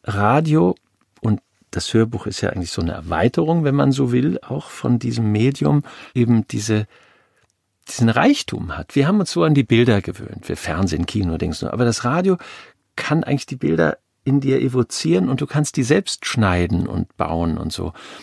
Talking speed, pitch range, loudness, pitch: 180 wpm, 95-140 Hz, -19 LUFS, 115 Hz